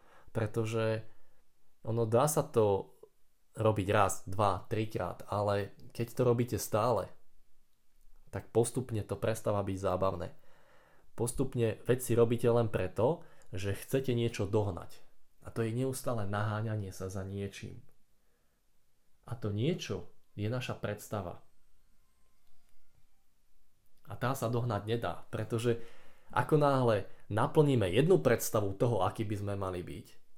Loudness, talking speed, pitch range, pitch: -33 LUFS, 120 wpm, 100-120 Hz, 110 Hz